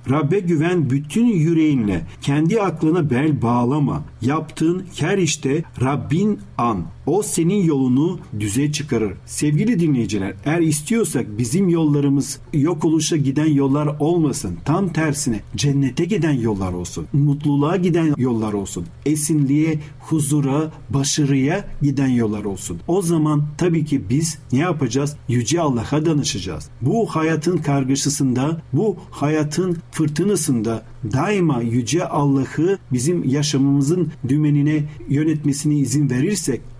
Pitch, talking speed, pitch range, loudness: 145 Hz, 115 wpm, 130-160 Hz, -19 LUFS